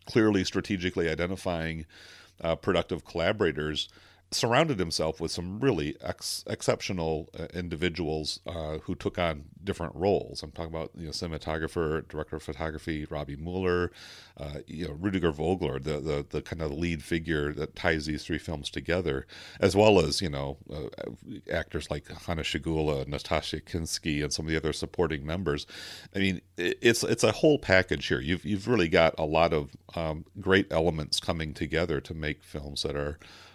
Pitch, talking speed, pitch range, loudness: 80 Hz, 170 wpm, 75-90 Hz, -29 LUFS